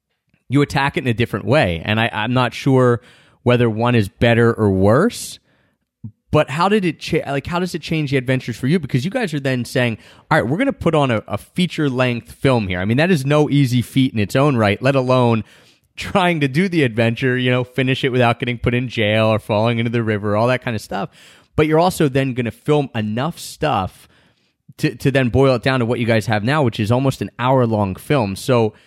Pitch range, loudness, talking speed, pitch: 115-145 Hz, -18 LUFS, 245 wpm, 125 Hz